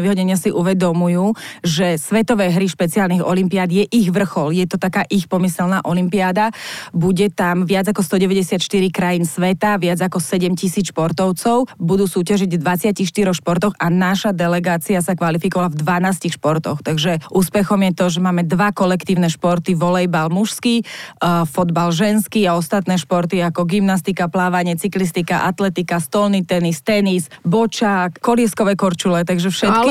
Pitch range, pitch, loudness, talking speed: 175-200 Hz, 185 Hz, -17 LUFS, 140 wpm